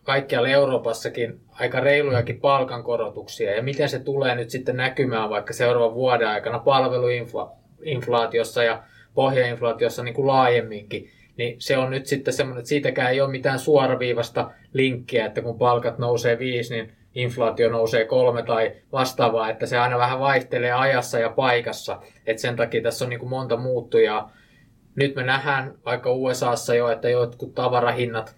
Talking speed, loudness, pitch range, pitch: 150 wpm, -22 LUFS, 120-135 Hz, 125 Hz